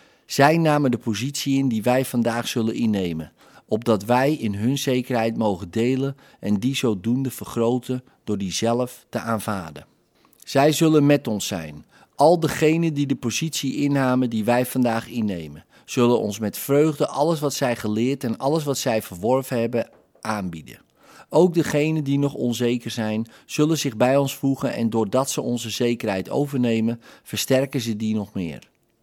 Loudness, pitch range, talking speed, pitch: -22 LUFS, 110-140 Hz, 160 wpm, 120 Hz